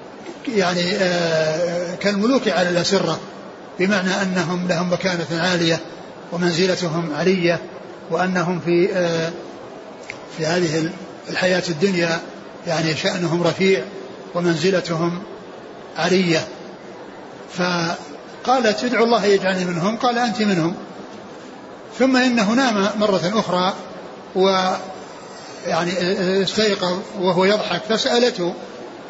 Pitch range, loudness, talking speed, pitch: 170-195 Hz, -19 LUFS, 85 wpm, 180 Hz